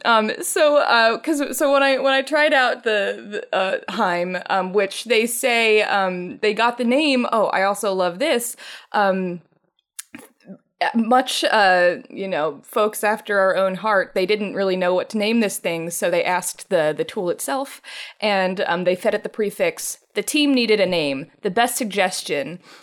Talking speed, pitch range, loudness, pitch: 185 wpm, 185-245 Hz, -20 LUFS, 210 Hz